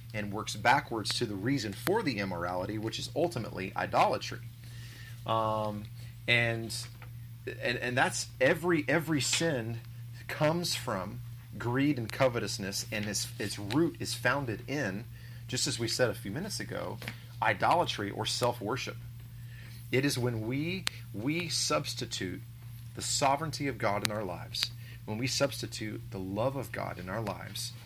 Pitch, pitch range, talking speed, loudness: 120 Hz, 110-125 Hz, 145 wpm, -32 LUFS